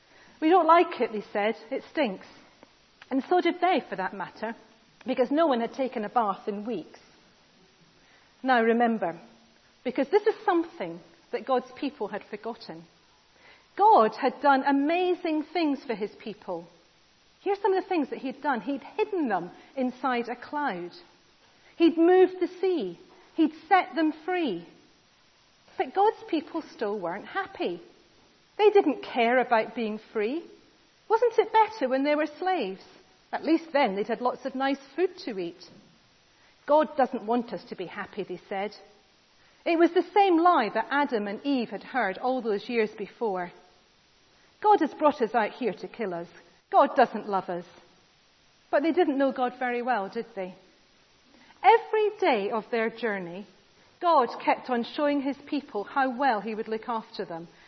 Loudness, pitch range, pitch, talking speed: -27 LUFS, 215-330 Hz, 255 Hz, 165 wpm